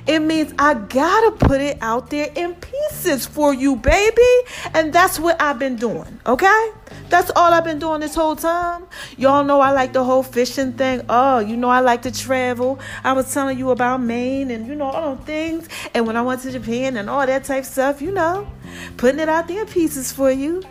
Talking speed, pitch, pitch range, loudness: 220 wpm, 275 Hz, 255-325 Hz, -18 LUFS